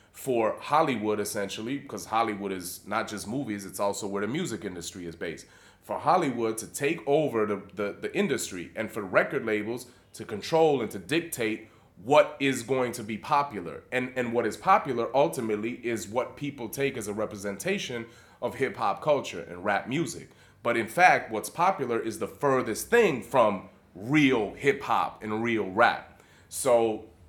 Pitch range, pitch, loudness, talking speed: 105-130 Hz, 115 Hz, -28 LUFS, 170 wpm